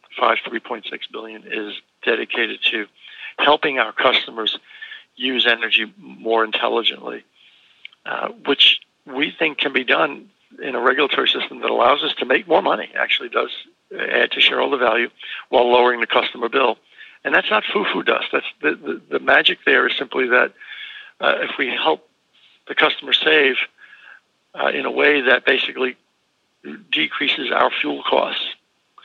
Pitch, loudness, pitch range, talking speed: 125 Hz, -18 LUFS, 115-130 Hz, 150 wpm